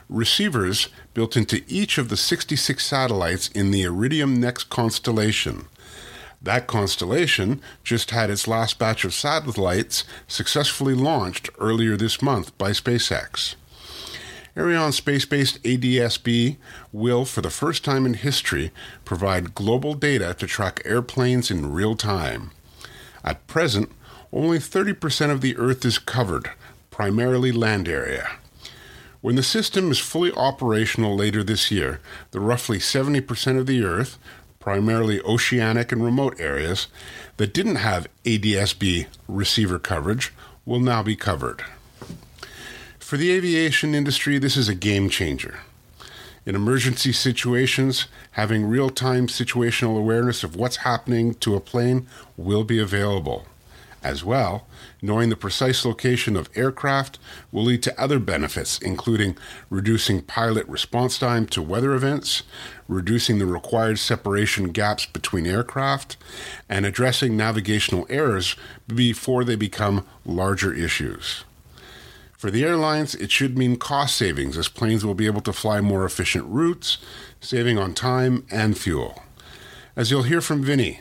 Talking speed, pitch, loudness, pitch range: 135 wpm, 115 Hz, -22 LUFS, 100-130 Hz